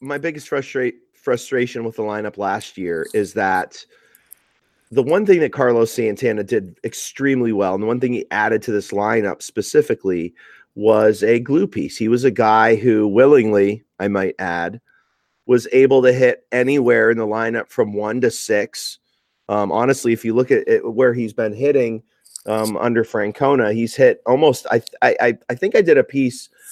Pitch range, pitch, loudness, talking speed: 105-135 Hz, 115 Hz, -18 LUFS, 180 wpm